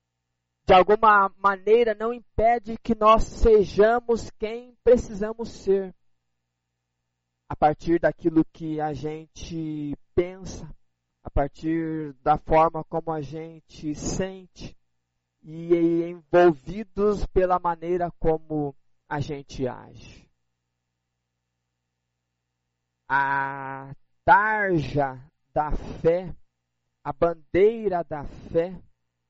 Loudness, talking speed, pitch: -24 LUFS, 85 wpm, 155 Hz